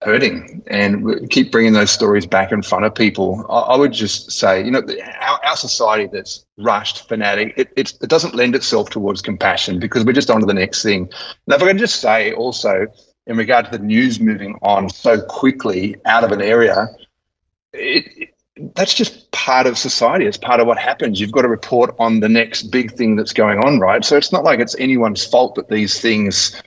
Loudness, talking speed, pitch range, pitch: -15 LUFS, 215 wpm, 105-150 Hz, 115 Hz